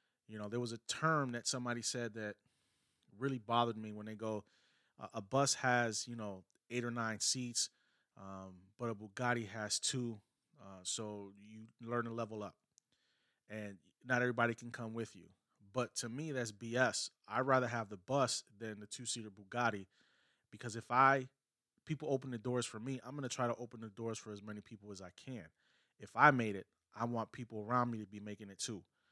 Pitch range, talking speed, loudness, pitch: 105-125 Hz, 200 wpm, -38 LUFS, 115 Hz